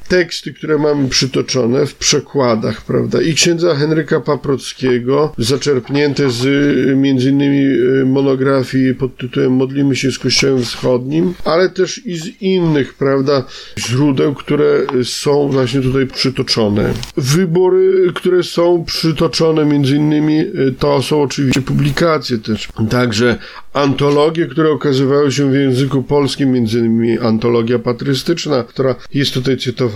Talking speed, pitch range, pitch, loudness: 120 wpm, 130-150 Hz, 140 Hz, -14 LUFS